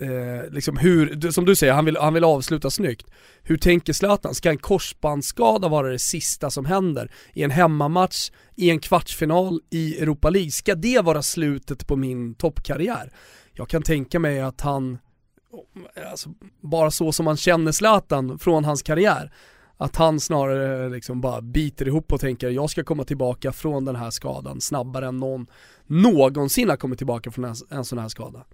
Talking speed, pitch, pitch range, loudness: 175 wpm, 150 Hz, 130-165 Hz, -22 LUFS